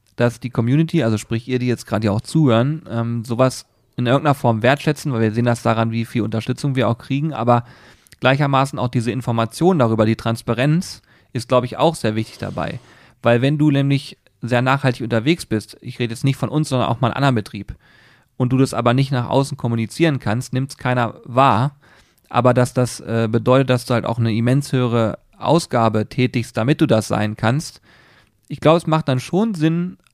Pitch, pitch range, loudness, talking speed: 125 Hz, 115-135 Hz, -19 LUFS, 205 wpm